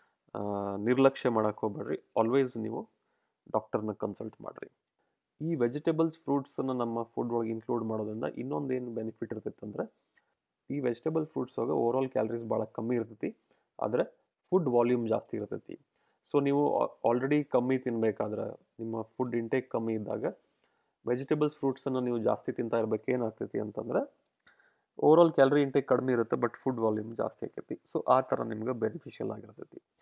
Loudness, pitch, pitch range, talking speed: -31 LUFS, 120 Hz, 115-135 Hz, 140 wpm